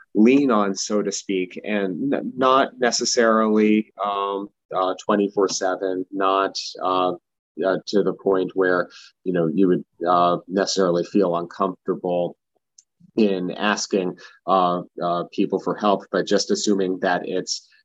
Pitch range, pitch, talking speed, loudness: 90-105 Hz, 95 Hz, 130 wpm, -21 LUFS